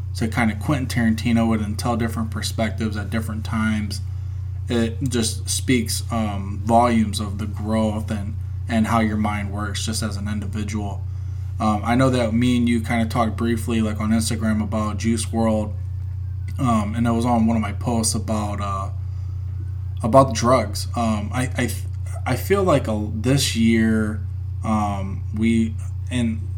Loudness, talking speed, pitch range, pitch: -22 LUFS, 165 wpm, 95-115 Hz, 105 Hz